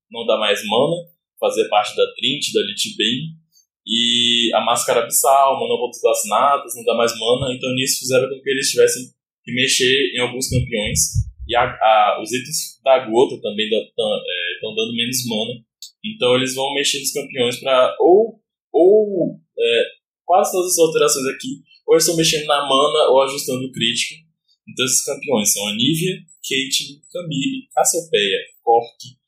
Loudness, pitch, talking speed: -17 LUFS, 160 Hz, 170 wpm